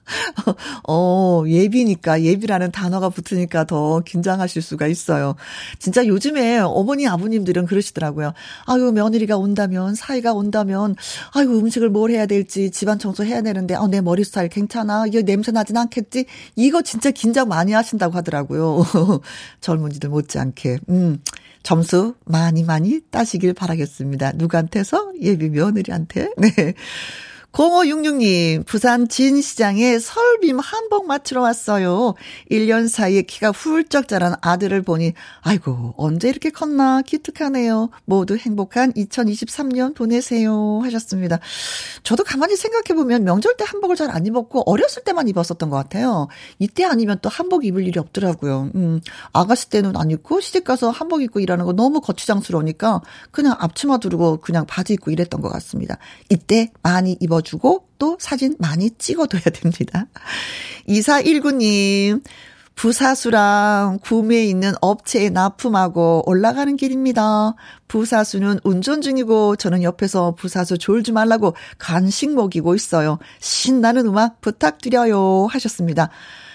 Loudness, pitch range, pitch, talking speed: -18 LUFS, 175-240 Hz, 205 Hz, 325 characters per minute